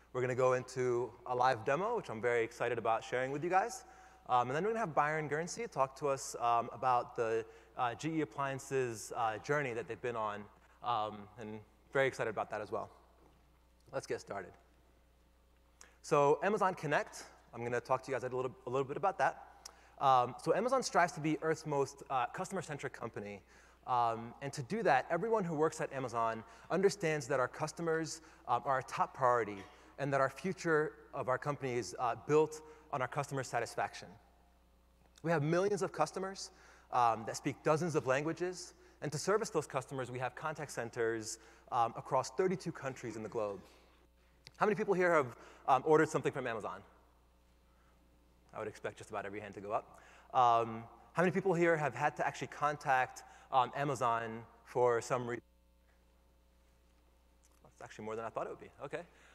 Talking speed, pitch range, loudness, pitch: 190 wpm, 110-155 Hz, -36 LUFS, 130 Hz